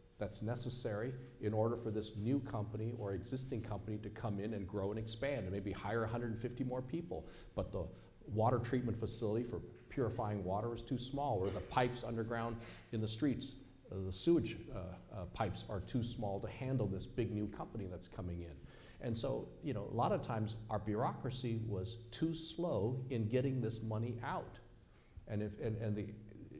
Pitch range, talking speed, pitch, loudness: 105-125 Hz, 185 wpm, 110 Hz, -41 LUFS